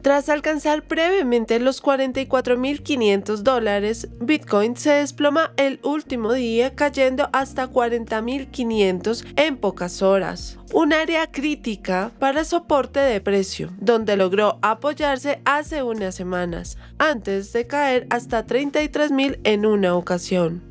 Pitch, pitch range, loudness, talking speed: 250 Hz, 210-285 Hz, -21 LUFS, 115 wpm